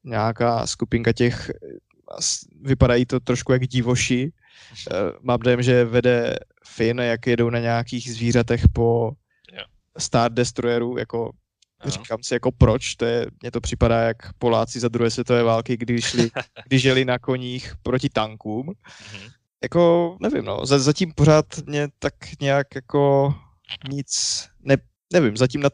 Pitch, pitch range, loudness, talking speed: 120 Hz, 115-130 Hz, -21 LUFS, 140 wpm